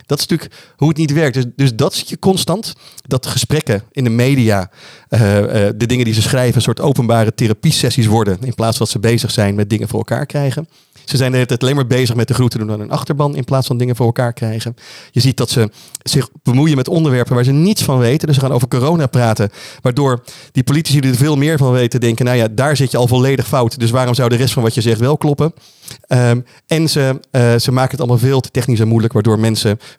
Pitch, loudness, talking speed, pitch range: 125 Hz, -14 LUFS, 255 wpm, 115-140 Hz